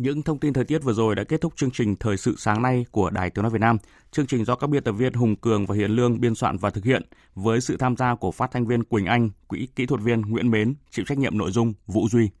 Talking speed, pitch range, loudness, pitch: 300 wpm, 110-130 Hz, -23 LUFS, 120 Hz